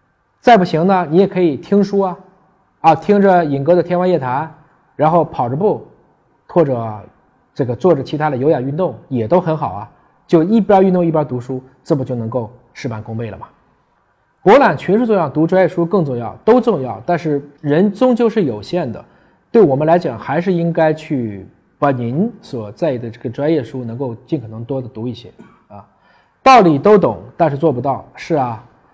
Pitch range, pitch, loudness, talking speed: 125-180 Hz, 160 Hz, -15 LUFS, 275 characters per minute